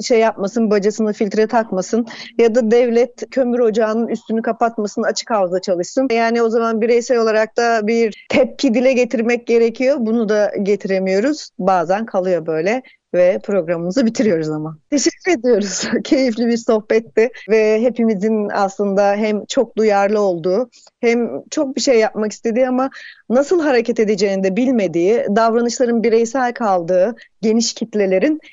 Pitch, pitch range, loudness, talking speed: 225 Hz, 205-245 Hz, -17 LUFS, 135 wpm